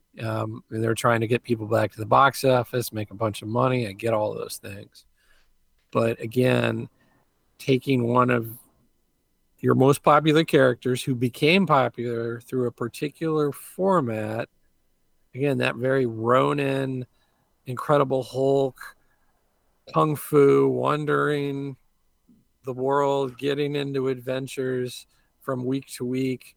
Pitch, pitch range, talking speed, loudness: 130 Hz, 115-140 Hz, 125 wpm, -24 LUFS